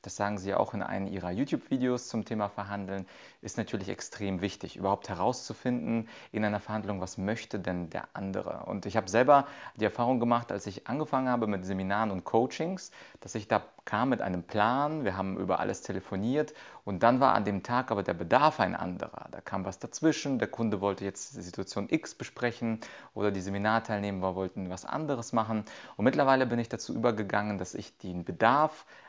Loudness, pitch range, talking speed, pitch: -31 LUFS, 95-120 Hz, 190 wpm, 105 Hz